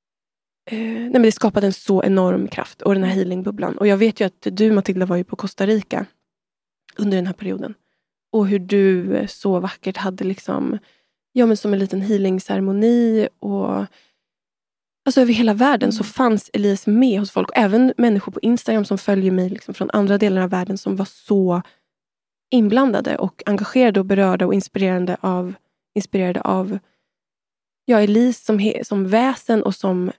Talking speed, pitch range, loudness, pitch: 175 wpm, 190-220 Hz, -19 LUFS, 200 Hz